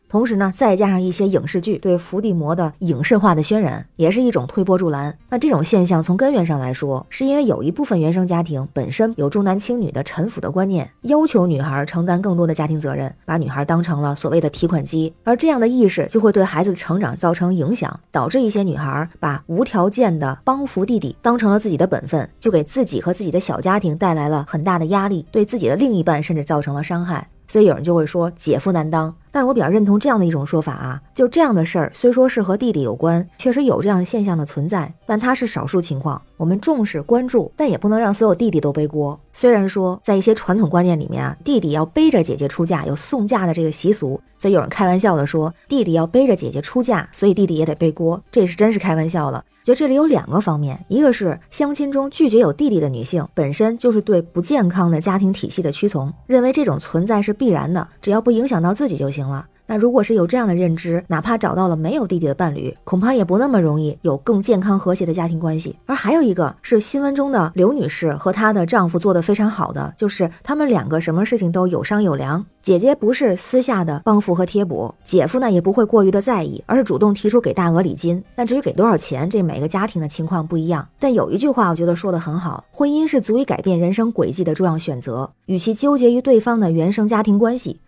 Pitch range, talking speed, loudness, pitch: 165-225 Hz, 370 characters per minute, -18 LUFS, 185 Hz